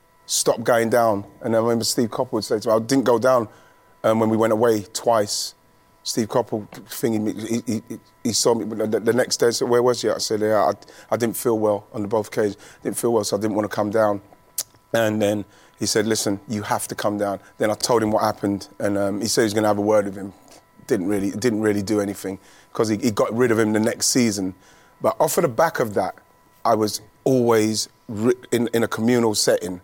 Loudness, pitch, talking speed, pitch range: -21 LUFS, 110 Hz, 245 wpm, 105-115 Hz